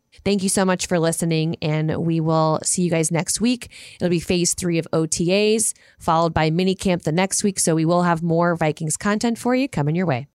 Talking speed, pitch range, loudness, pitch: 225 wpm, 160-190 Hz, -20 LUFS, 175 Hz